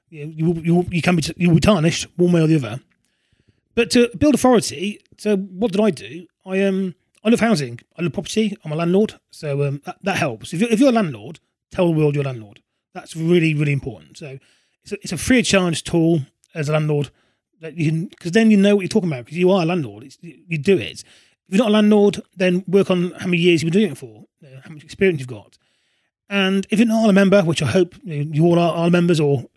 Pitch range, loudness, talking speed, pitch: 150-195 Hz, -18 LUFS, 260 wpm, 175 Hz